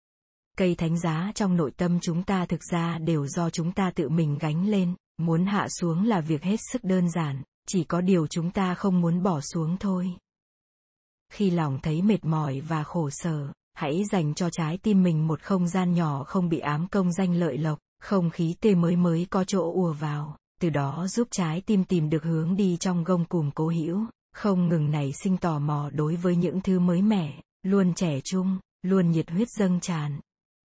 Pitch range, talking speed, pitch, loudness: 160-190 Hz, 205 wpm, 175 Hz, -26 LUFS